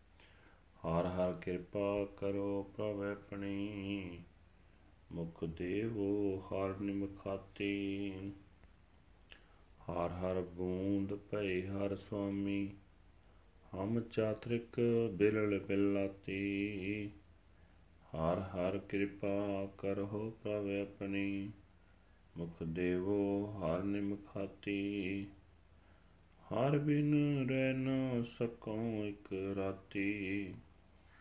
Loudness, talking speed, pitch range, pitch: -38 LUFS, 65 wpm, 90-100 Hz, 100 Hz